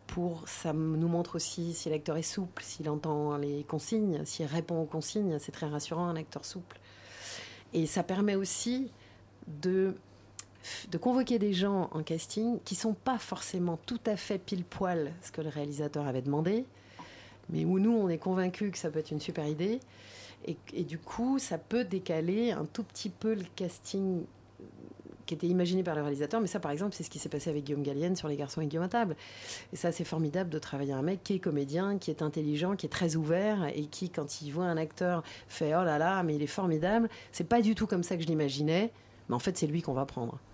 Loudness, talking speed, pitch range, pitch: -33 LUFS, 220 wpm, 150-195 Hz, 170 Hz